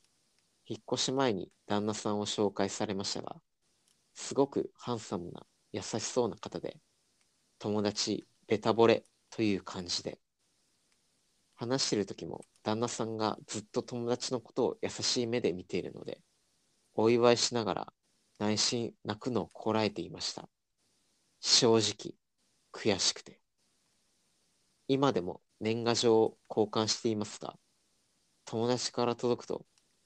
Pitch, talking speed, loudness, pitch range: 110 Hz, 255 characters per minute, -32 LUFS, 105-120 Hz